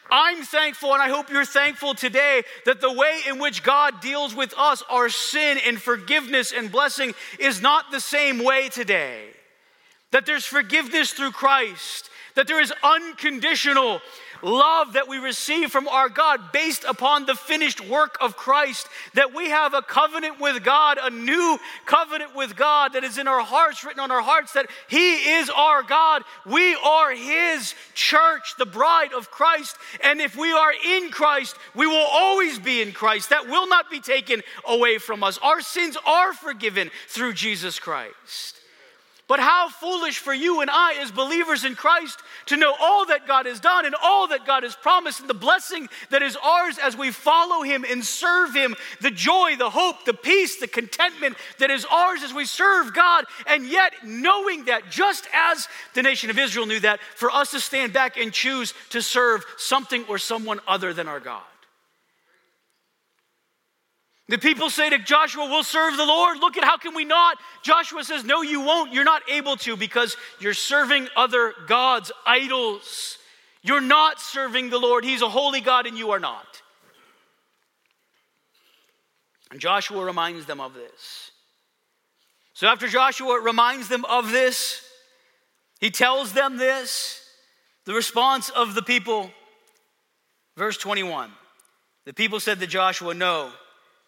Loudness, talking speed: -20 LUFS, 170 wpm